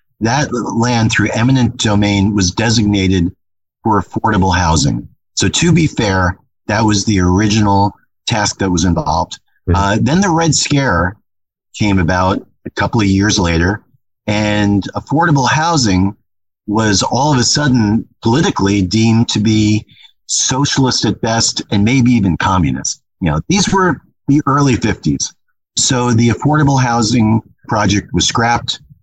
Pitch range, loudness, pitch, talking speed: 100-125 Hz, -13 LUFS, 110 Hz, 140 wpm